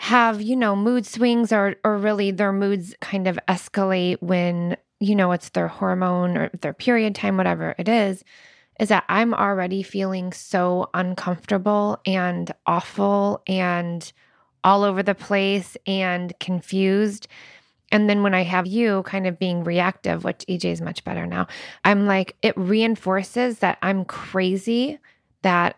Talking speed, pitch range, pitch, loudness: 155 wpm, 180-210 Hz, 195 Hz, -22 LUFS